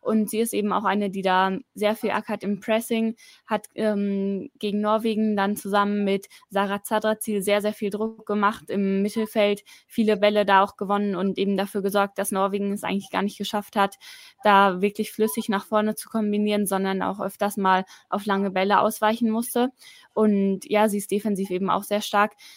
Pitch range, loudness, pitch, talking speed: 200-215 Hz, -24 LUFS, 205 Hz, 190 wpm